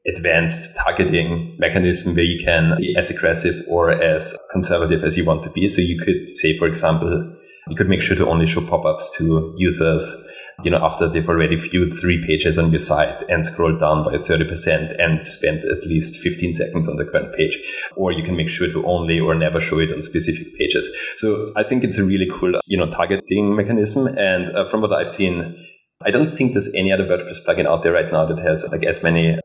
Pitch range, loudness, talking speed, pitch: 80-100 Hz, -19 LUFS, 220 wpm, 85 Hz